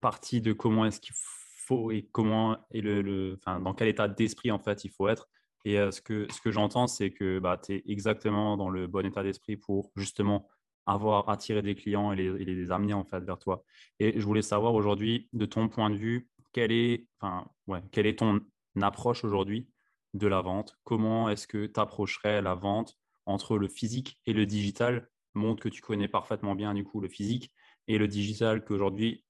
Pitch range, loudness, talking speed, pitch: 100-110 Hz, -31 LUFS, 210 wpm, 105 Hz